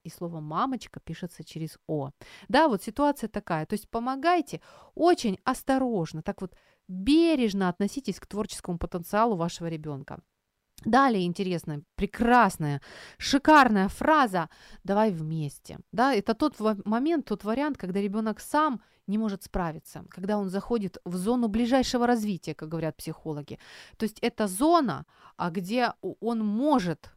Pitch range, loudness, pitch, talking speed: 175-245 Hz, -27 LUFS, 205 Hz, 135 wpm